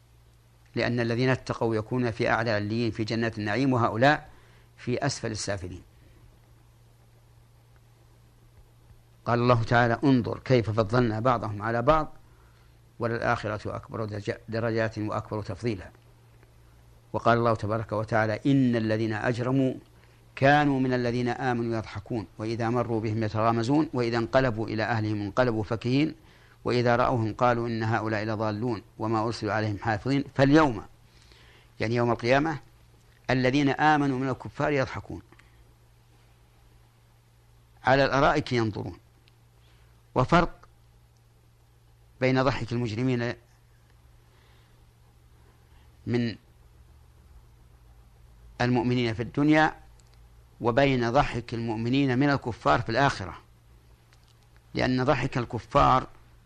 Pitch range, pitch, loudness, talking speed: 110-120 Hz, 115 Hz, -26 LUFS, 95 wpm